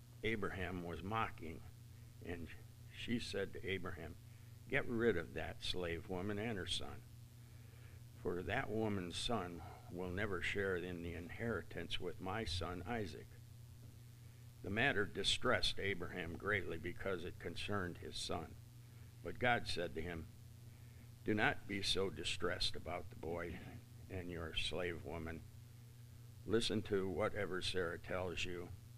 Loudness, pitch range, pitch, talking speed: -42 LUFS, 90-115 Hz, 110 Hz, 135 wpm